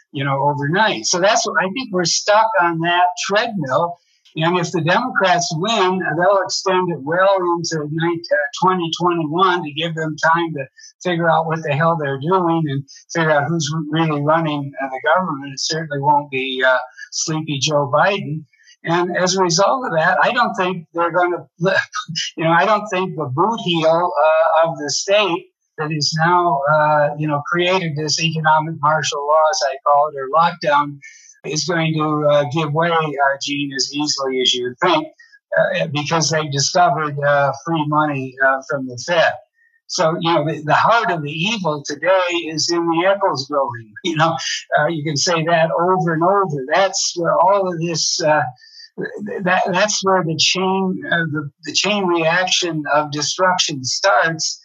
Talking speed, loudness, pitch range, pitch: 180 wpm, -17 LUFS, 150-185 Hz, 165 Hz